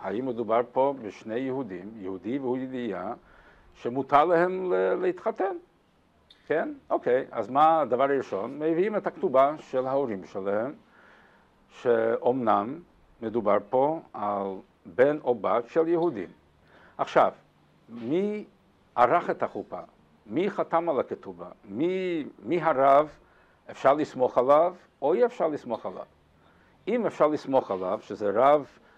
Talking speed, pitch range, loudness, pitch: 120 wpm, 120-170 Hz, -26 LUFS, 140 Hz